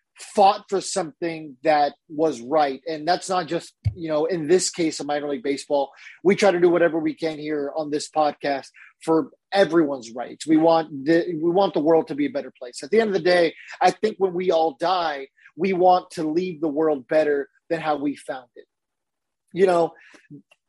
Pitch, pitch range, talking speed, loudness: 160 Hz, 145-180 Hz, 205 wpm, -22 LUFS